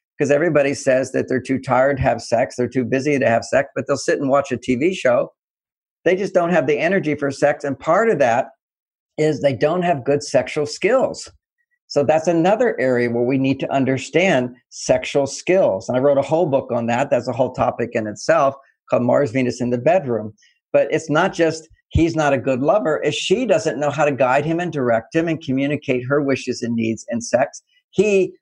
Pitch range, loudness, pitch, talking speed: 130-160 Hz, -19 LUFS, 140 Hz, 215 wpm